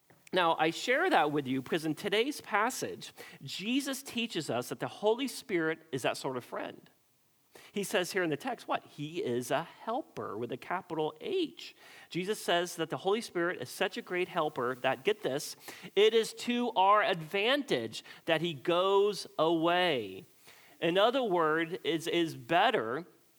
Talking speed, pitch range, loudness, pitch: 165 wpm, 160-225 Hz, -32 LUFS, 180 Hz